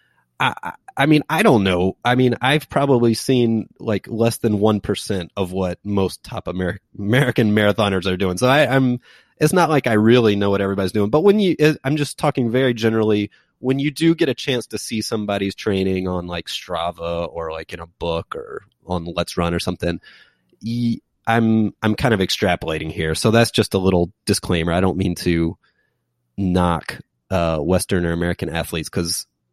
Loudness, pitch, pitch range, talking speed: -19 LUFS, 100 Hz, 90-120 Hz, 190 wpm